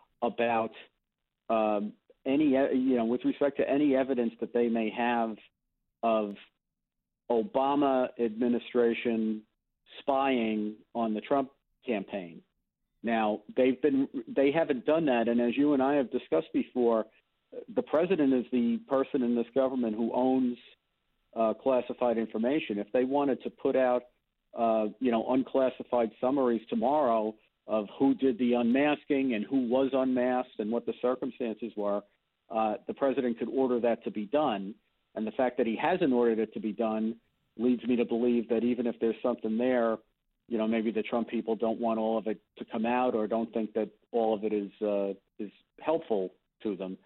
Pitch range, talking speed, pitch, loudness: 110-130 Hz, 170 wpm, 120 Hz, -29 LUFS